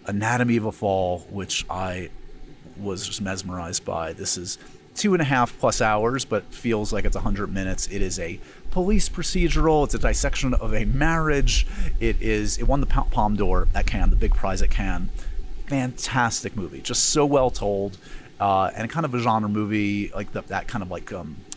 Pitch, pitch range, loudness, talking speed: 105 Hz, 95-125 Hz, -24 LUFS, 195 wpm